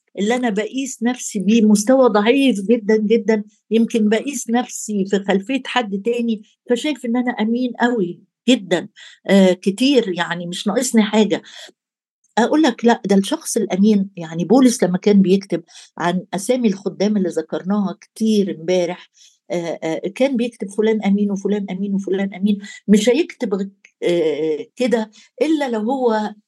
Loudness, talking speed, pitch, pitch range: -18 LUFS, 135 wpm, 215 Hz, 195-240 Hz